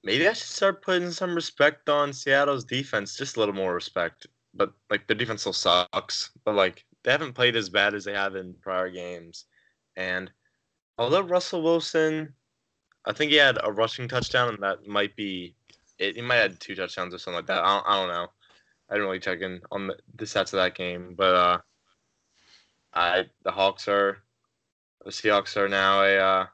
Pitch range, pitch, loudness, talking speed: 95-140 Hz, 105 Hz, -25 LUFS, 200 wpm